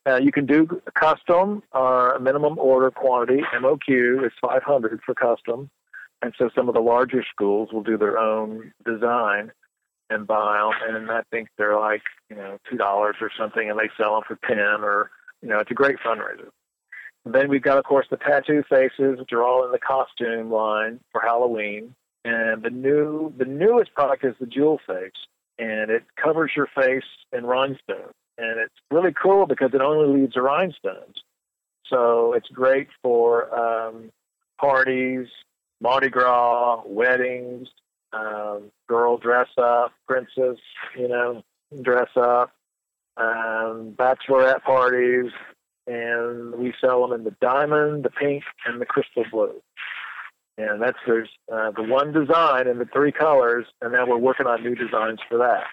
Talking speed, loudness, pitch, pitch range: 165 wpm, -21 LUFS, 125 Hz, 115-135 Hz